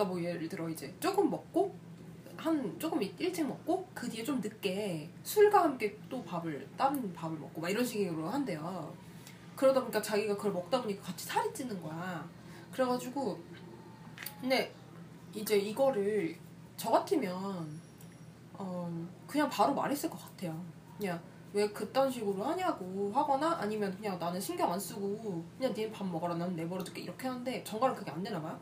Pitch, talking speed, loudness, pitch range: 195 Hz, 325 characters per minute, -34 LUFS, 170-250 Hz